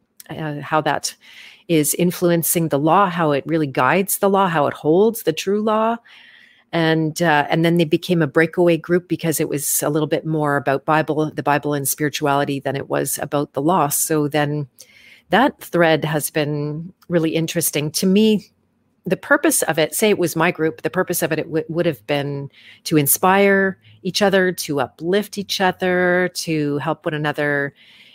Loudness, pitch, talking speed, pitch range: -19 LUFS, 160 Hz, 185 wpm, 150-180 Hz